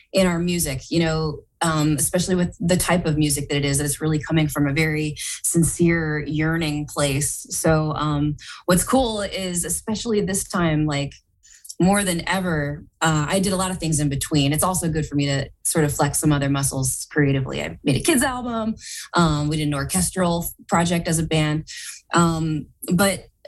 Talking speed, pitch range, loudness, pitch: 190 wpm, 150-180 Hz, -21 LUFS, 160 Hz